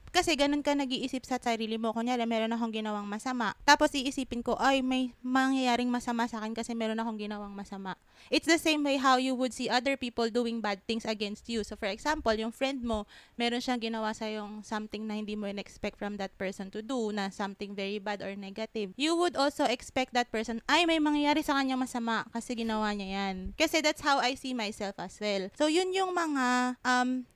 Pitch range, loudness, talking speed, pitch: 215-265 Hz, -31 LUFS, 215 wpm, 235 Hz